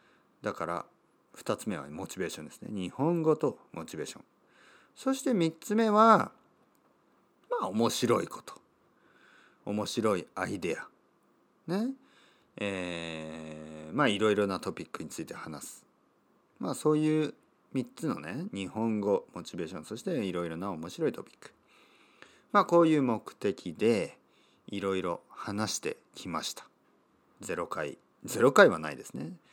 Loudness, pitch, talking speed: -31 LUFS, 110 Hz, 260 characters per minute